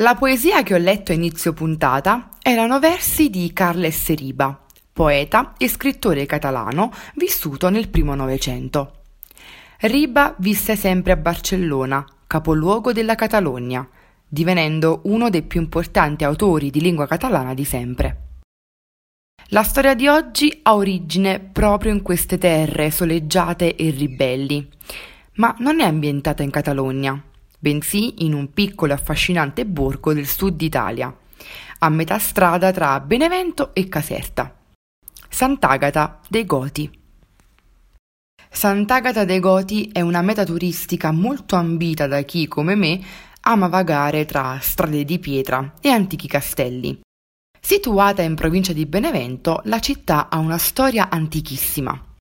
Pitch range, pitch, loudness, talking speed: 145-205 Hz, 170 Hz, -19 LUFS, 130 wpm